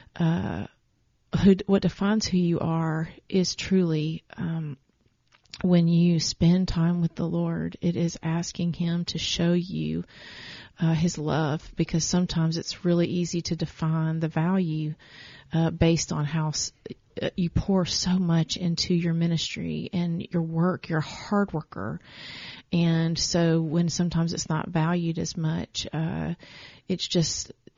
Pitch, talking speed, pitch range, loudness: 170 Hz, 145 wpm, 160-175 Hz, -26 LUFS